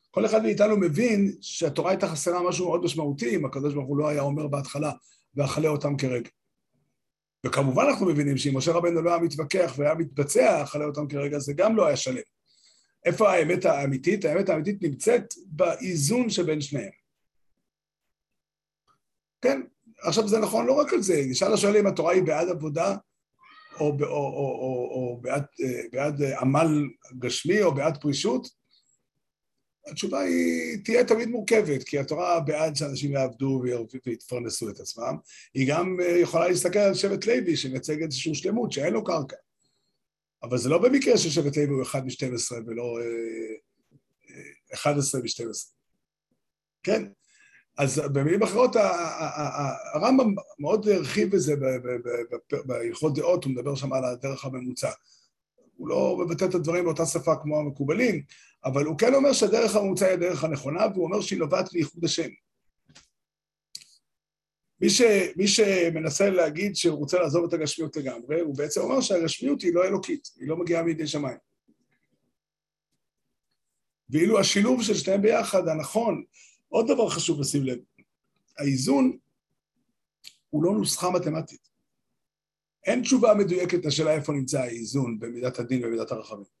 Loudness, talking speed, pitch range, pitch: -25 LUFS, 145 wpm, 140-190 Hz, 160 Hz